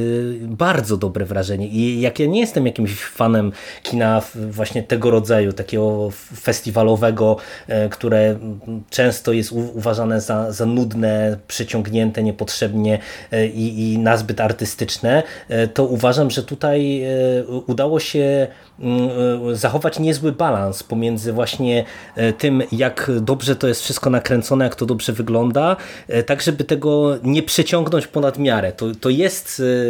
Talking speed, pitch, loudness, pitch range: 125 wpm, 115 Hz, -19 LUFS, 110-135 Hz